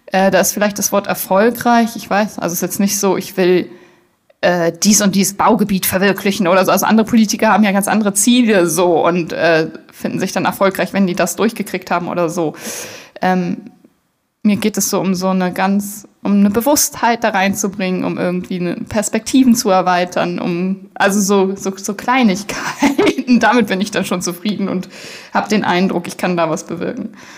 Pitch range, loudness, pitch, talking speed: 185-215 Hz, -15 LUFS, 195 Hz, 190 wpm